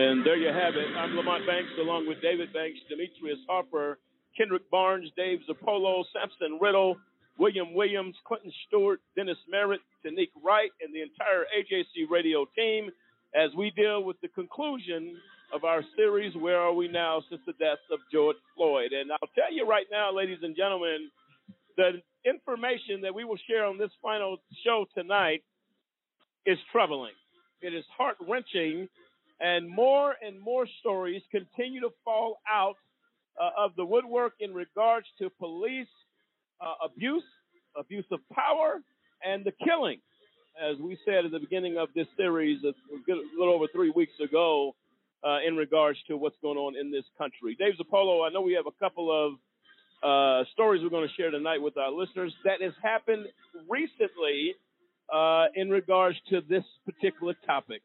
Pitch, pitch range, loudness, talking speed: 190 Hz, 165-225 Hz, -29 LUFS, 165 wpm